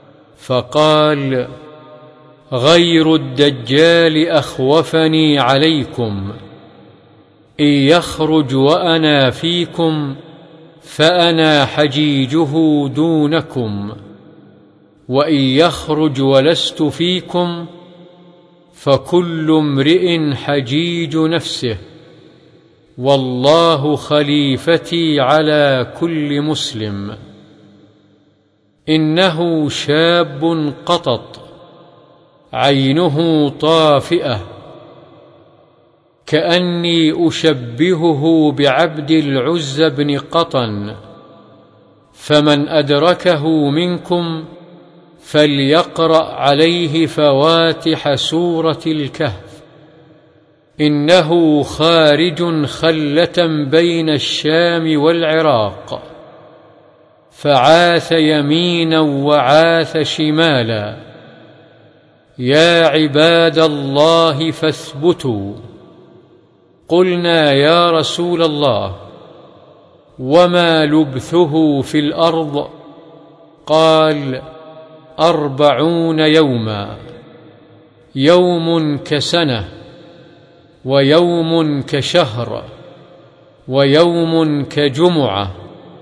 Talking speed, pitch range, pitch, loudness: 50 wpm, 145-165 Hz, 155 Hz, -13 LUFS